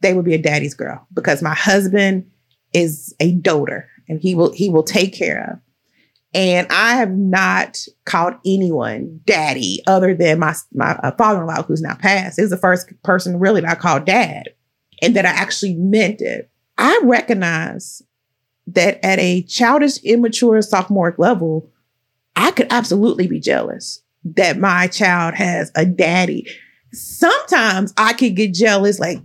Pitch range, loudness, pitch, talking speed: 170-210 Hz, -16 LUFS, 185 Hz, 160 wpm